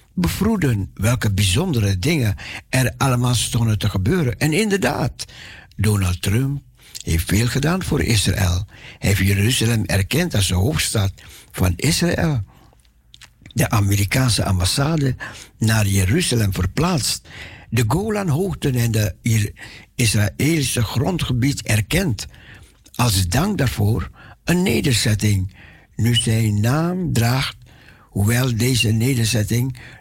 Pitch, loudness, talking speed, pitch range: 115 Hz, -19 LUFS, 105 wpm, 100-130 Hz